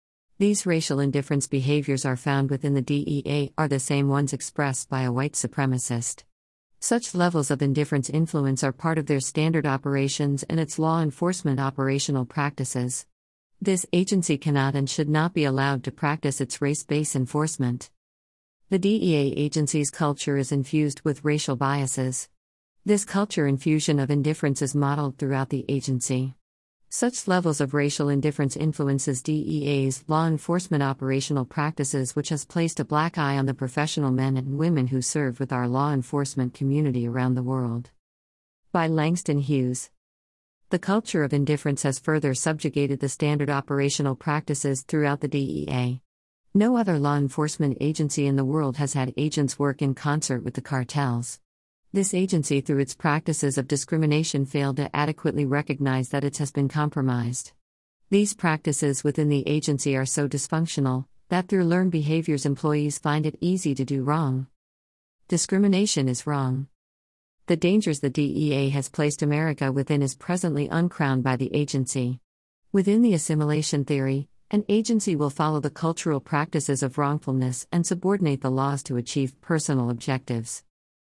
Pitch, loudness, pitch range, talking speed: 145 Hz, -25 LUFS, 135-155 Hz, 155 wpm